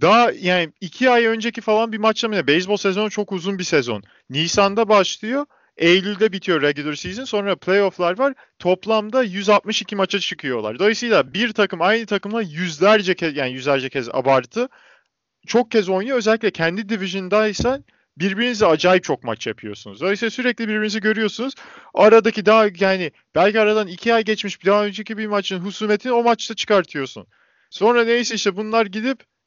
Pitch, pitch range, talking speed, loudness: 210 Hz, 185-225 Hz, 155 wpm, -19 LUFS